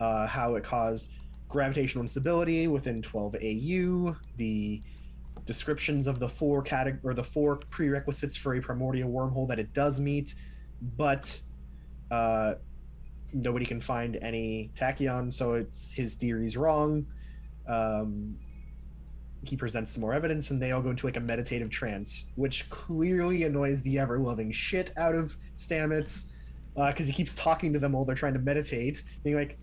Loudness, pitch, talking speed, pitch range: -31 LUFS, 125 Hz, 155 wpm, 110-145 Hz